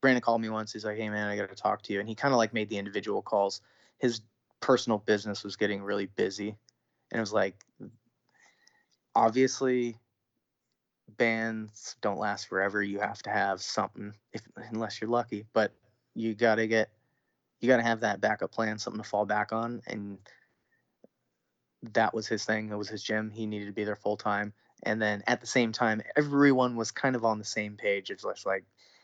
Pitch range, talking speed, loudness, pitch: 105-115 Hz, 200 wpm, -30 LUFS, 110 Hz